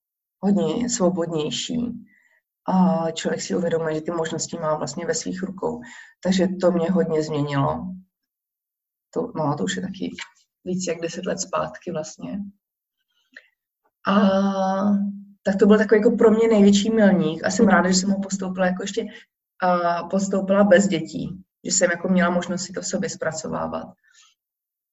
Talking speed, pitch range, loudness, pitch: 155 wpm, 170-205 Hz, -22 LUFS, 185 Hz